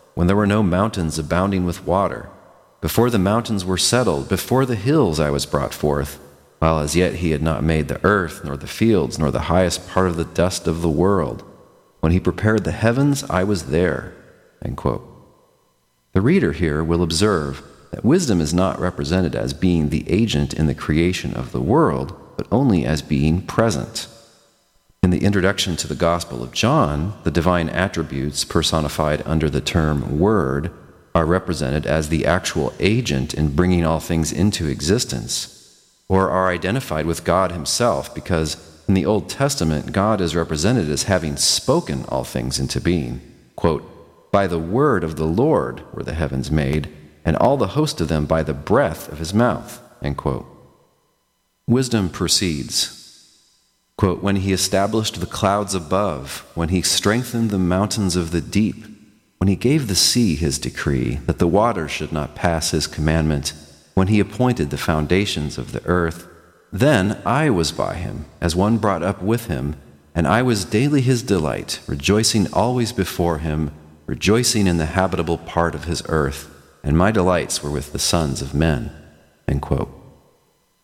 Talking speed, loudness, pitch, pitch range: 170 wpm, -20 LUFS, 85 Hz, 75-95 Hz